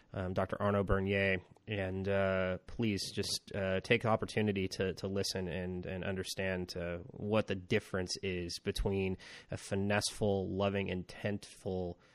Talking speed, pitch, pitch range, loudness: 140 wpm, 95 Hz, 95-100 Hz, -36 LUFS